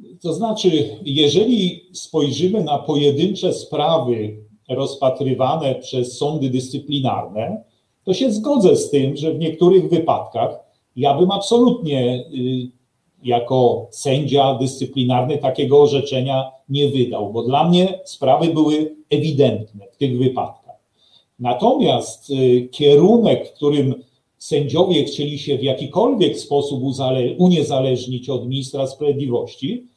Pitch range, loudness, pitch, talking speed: 130-155 Hz, -18 LUFS, 140 Hz, 105 wpm